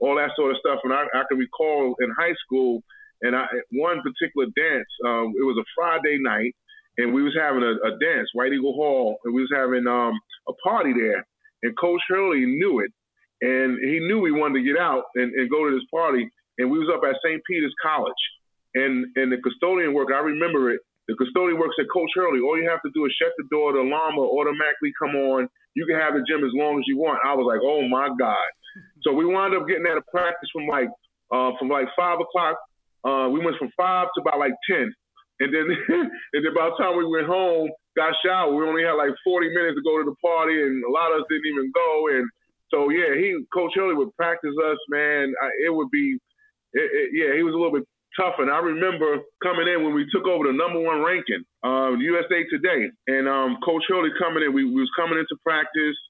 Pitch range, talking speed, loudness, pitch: 135-180 Hz, 235 wpm, -23 LUFS, 160 Hz